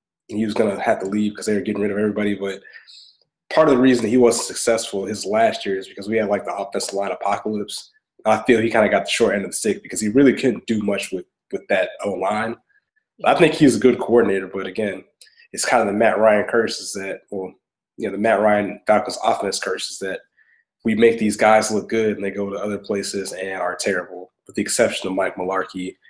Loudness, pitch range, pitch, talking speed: -20 LUFS, 100-120 Hz, 105 Hz, 245 wpm